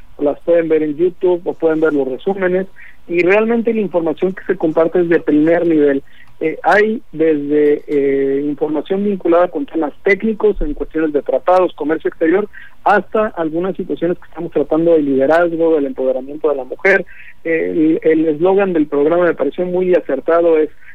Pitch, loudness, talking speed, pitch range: 165 Hz, -15 LUFS, 170 wpm, 150-185 Hz